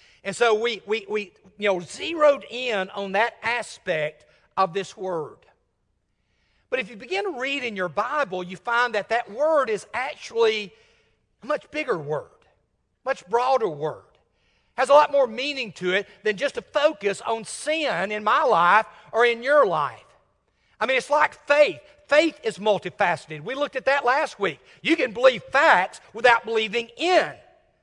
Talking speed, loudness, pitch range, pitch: 170 wpm, -23 LUFS, 200-295 Hz, 235 Hz